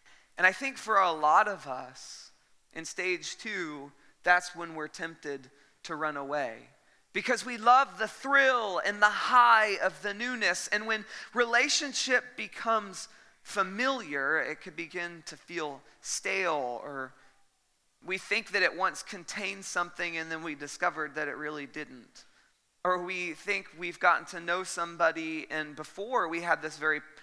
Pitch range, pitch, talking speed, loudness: 155-215 Hz, 175 Hz, 155 wpm, -29 LUFS